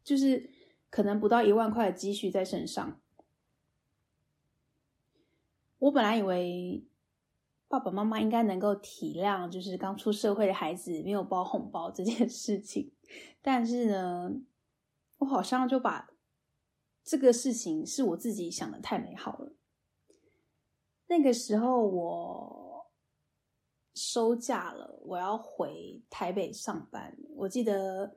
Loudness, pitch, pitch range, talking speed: -31 LUFS, 220 Hz, 195-255 Hz, 185 characters per minute